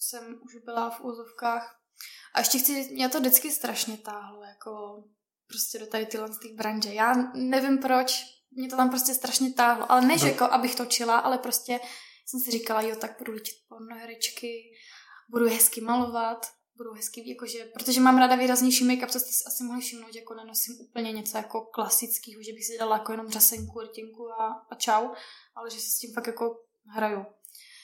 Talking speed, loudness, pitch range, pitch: 190 wpm, -26 LUFS, 225-250 Hz, 235 Hz